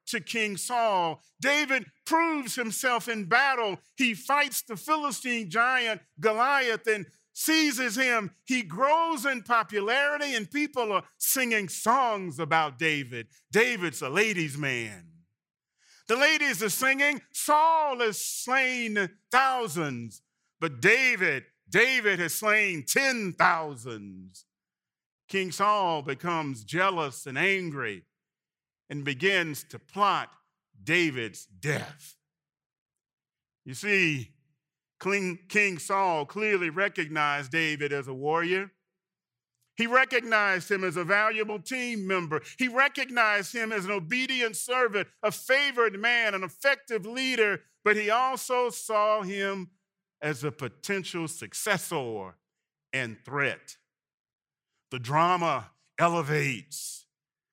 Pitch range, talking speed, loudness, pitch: 155-240 Hz, 105 wpm, -26 LUFS, 200 Hz